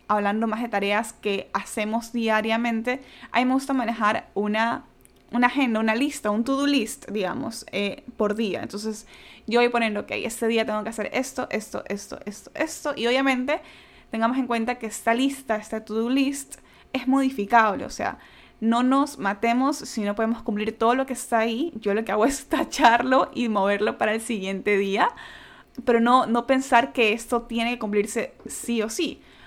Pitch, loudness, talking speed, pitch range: 230 Hz, -24 LUFS, 185 wpm, 215-260 Hz